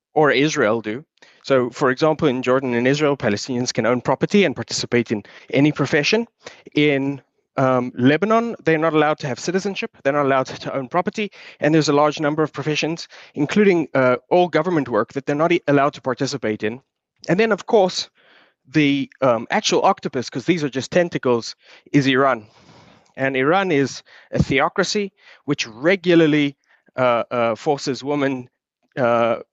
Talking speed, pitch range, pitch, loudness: 165 wpm, 125-160 Hz, 140 Hz, -19 LUFS